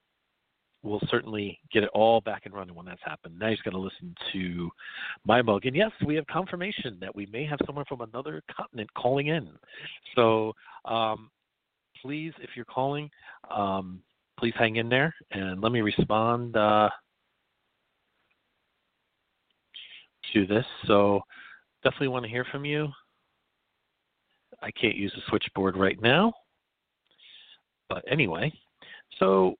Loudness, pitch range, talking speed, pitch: -28 LUFS, 100-140 Hz, 140 wpm, 115 Hz